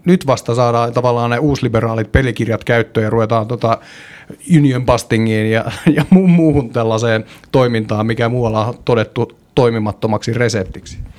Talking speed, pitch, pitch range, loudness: 125 wpm, 115 Hz, 110-125 Hz, -15 LUFS